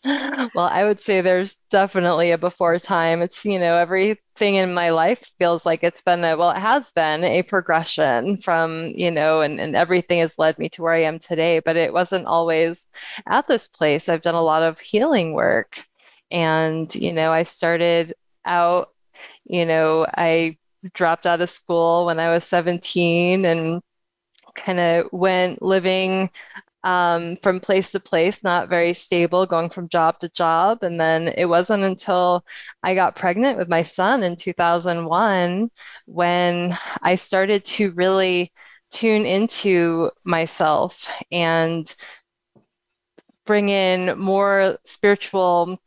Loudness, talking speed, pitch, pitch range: -19 LUFS, 150 wpm, 175 Hz, 165-190 Hz